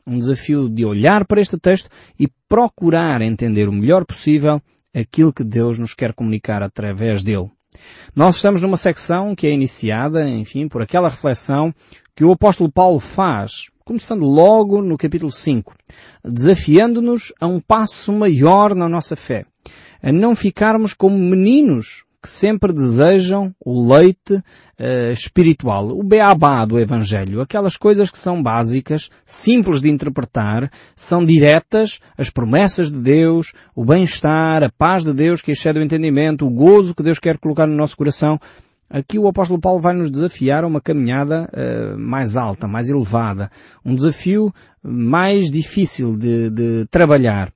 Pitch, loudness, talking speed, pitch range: 155 Hz, -15 LUFS, 150 wpm, 125-185 Hz